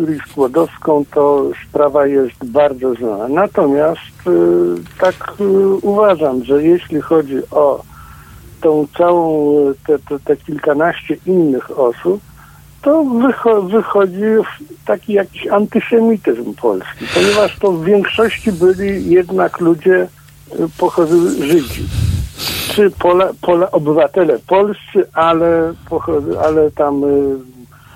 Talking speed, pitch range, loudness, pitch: 110 wpm, 145-200 Hz, -14 LUFS, 170 Hz